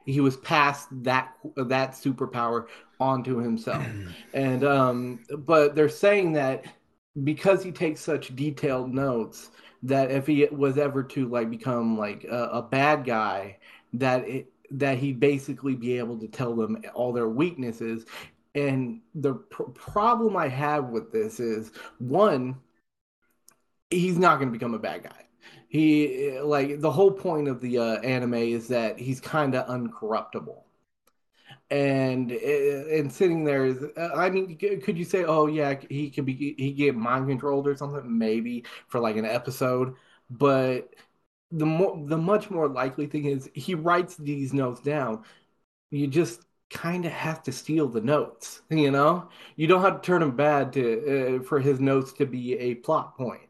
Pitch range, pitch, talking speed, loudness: 125-150 Hz, 140 Hz, 165 wpm, -26 LUFS